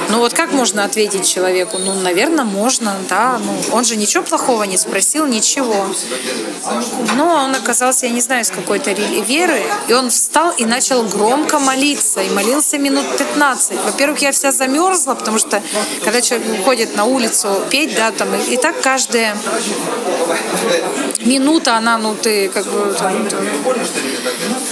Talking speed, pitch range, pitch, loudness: 155 wpm, 210-275 Hz, 245 Hz, -14 LUFS